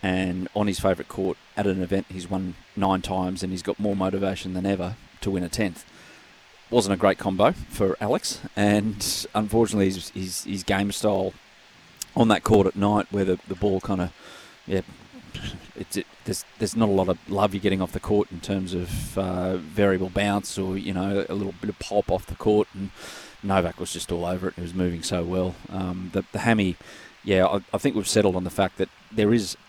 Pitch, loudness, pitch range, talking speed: 95 Hz, -25 LUFS, 90-100 Hz, 220 wpm